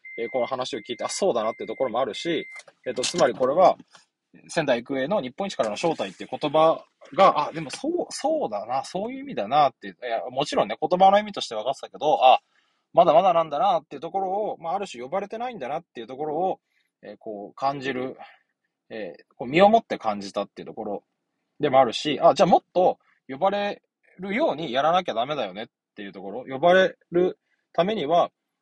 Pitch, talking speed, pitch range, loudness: 170 Hz, 420 characters per minute, 130-200 Hz, -24 LUFS